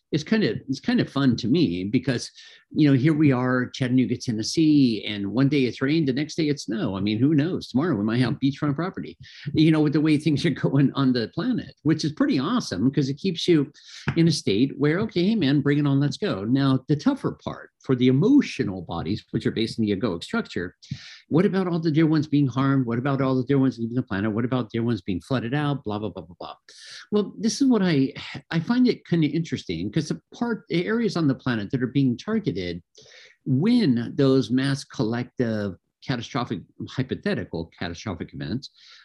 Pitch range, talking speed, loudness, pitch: 120-155 Hz, 220 wpm, -24 LUFS, 135 Hz